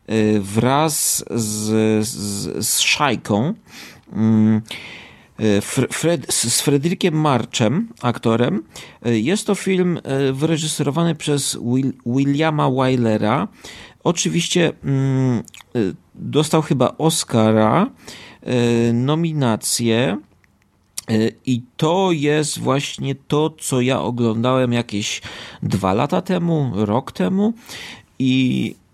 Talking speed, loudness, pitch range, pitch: 75 wpm, -19 LUFS, 110-155 Hz, 130 Hz